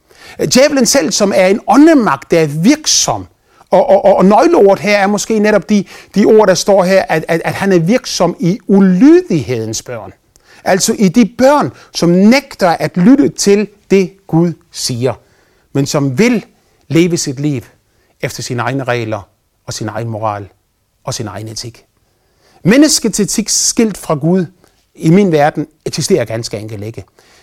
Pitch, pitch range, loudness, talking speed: 180 Hz, 130-205 Hz, -11 LUFS, 160 wpm